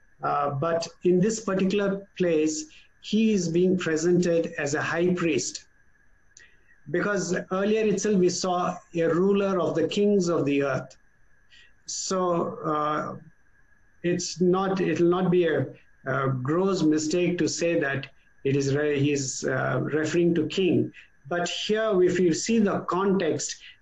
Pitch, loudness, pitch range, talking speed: 175 Hz, -25 LUFS, 155-185 Hz, 145 wpm